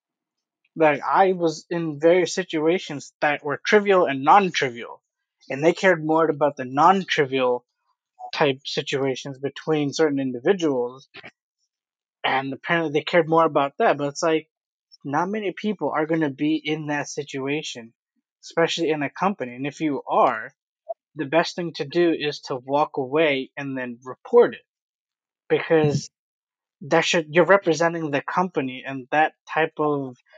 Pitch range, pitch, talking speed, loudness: 140-175 Hz, 155 Hz, 150 wpm, -22 LUFS